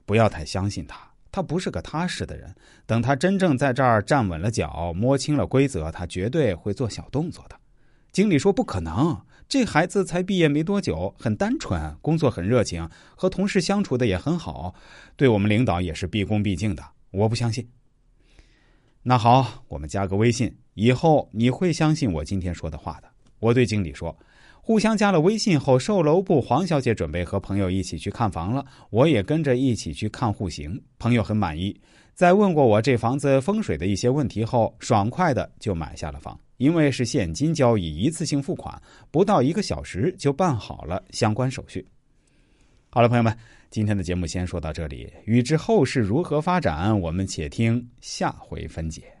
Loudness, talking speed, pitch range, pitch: -23 LUFS, 285 characters per minute, 95-140 Hz, 120 Hz